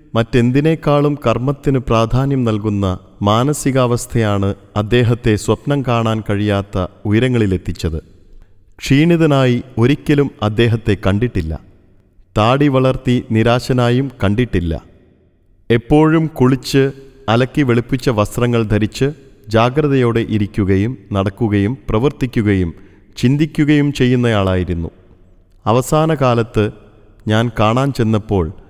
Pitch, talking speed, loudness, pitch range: 115 Hz, 75 wpm, -15 LUFS, 100-130 Hz